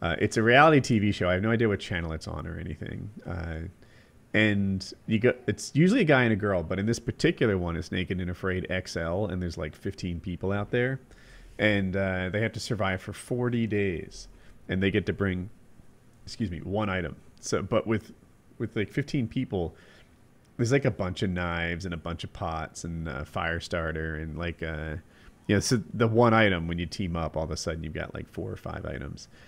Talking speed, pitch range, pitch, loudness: 220 wpm, 85-110 Hz, 95 Hz, -28 LUFS